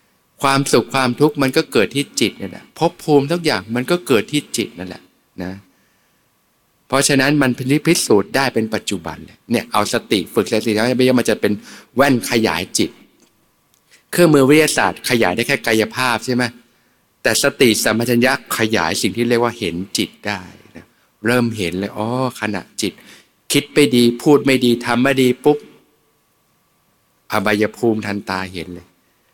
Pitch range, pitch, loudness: 105-135 Hz, 120 Hz, -17 LUFS